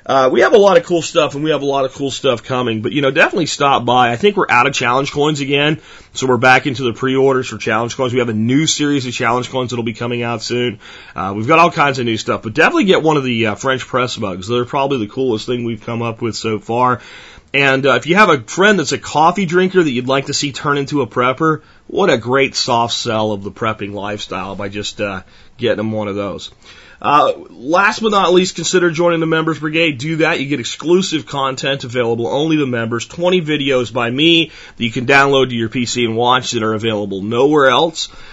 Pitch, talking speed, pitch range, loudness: 130 Hz, 245 wpm, 115-145 Hz, -15 LUFS